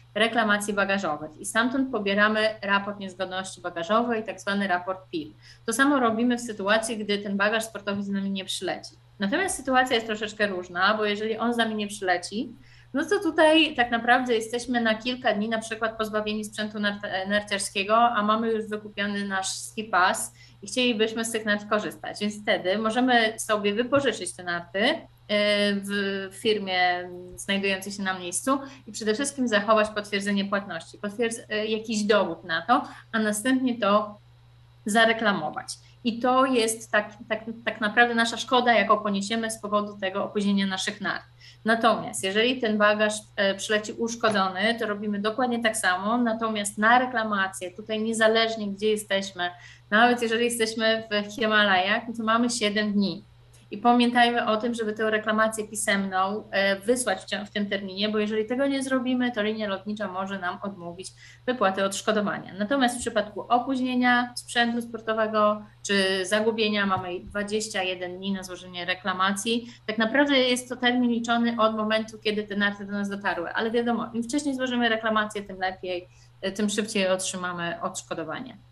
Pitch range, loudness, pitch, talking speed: 195-230 Hz, -25 LUFS, 215 Hz, 155 wpm